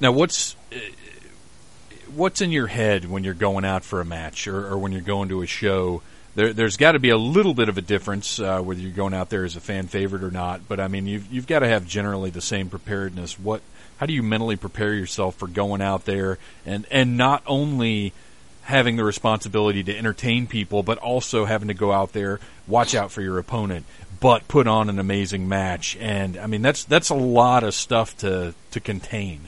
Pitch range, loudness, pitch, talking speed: 95-115 Hz, -22 LUFS, 100 Hz, 215 wpm